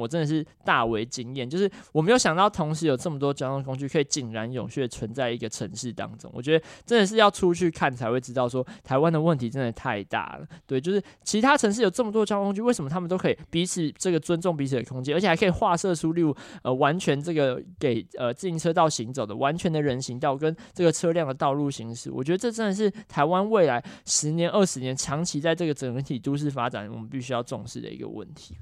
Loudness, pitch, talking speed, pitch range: -25 LUFS, 150 Hz, 375 characters per minute, 130-175 Hz